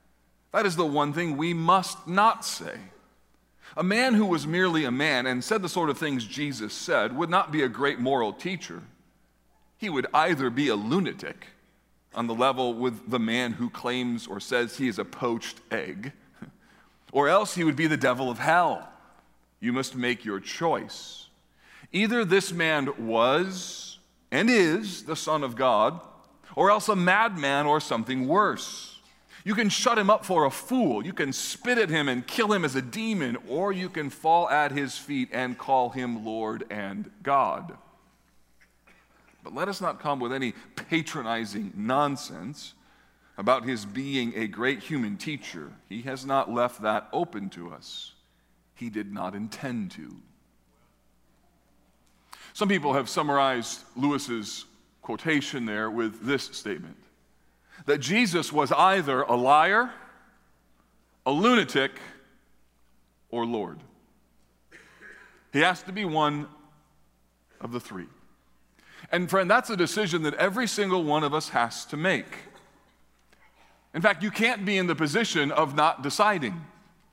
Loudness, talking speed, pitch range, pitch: -26 LUFS, 155 wpm, 115-180 Hz, 140 Hz